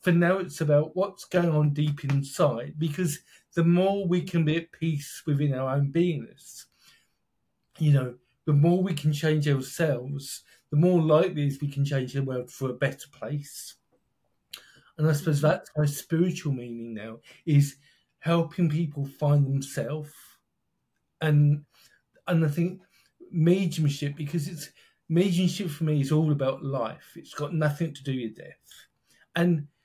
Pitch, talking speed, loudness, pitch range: 150 Hz, 155 wpm, -26 LUFS, 140-170 Hz